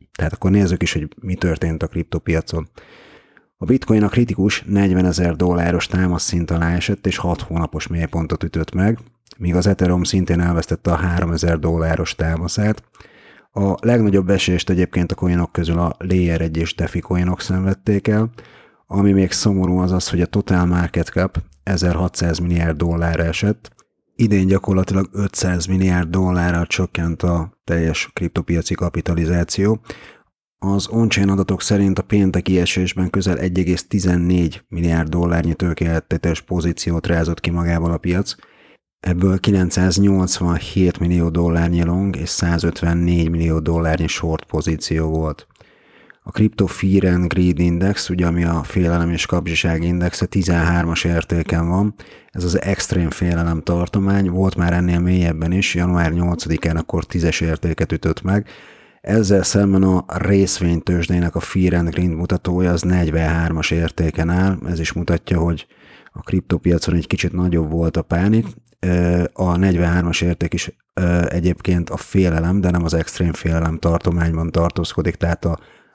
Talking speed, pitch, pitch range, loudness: 140 wpm, 90 Hz, 85-95 Hz, -18 LUFS